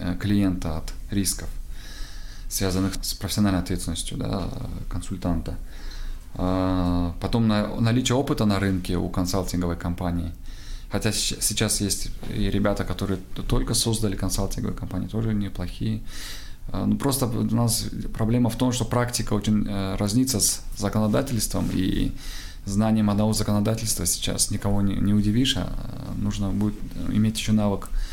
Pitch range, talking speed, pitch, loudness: 90-110 Hz, 120 wpm, 100 Hz, -25 LUFS